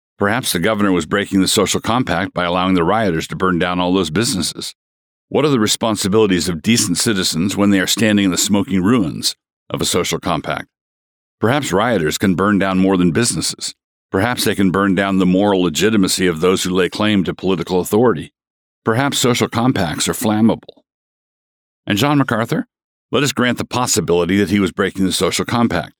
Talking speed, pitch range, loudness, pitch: 185 wpm, 90-110 Hz, -16 LUFS, 95 Hz